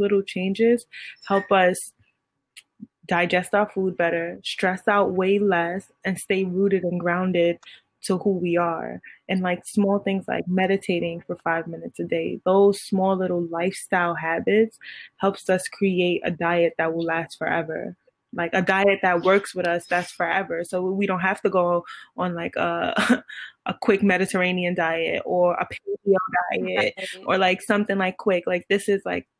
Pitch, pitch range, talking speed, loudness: 185 Hz, 175-195 Hz, 165 wpm, -23 LUFS